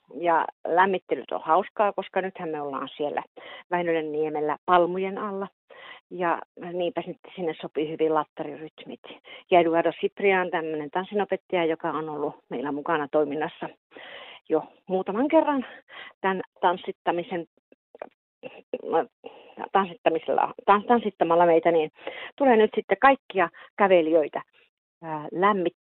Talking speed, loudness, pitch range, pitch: 95 wpm, -25 LUFS, 160-200 Hz, 180 Hz